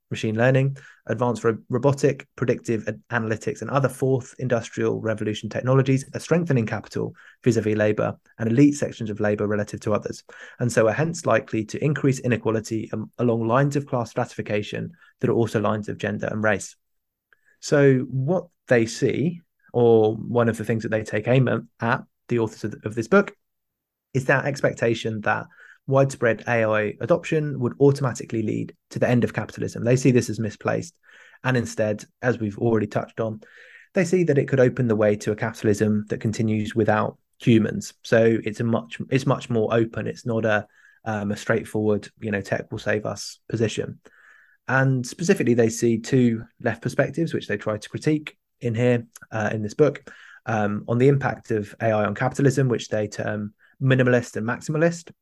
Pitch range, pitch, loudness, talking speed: 110-130 Hz, 115 Hz, -23 LUFS, 175 wpm